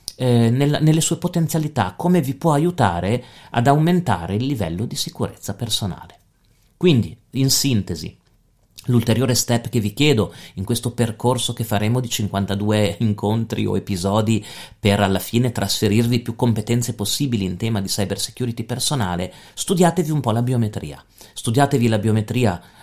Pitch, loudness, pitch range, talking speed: 115 Hz, -20 LUFS, 100-130 Hz, 145 wpm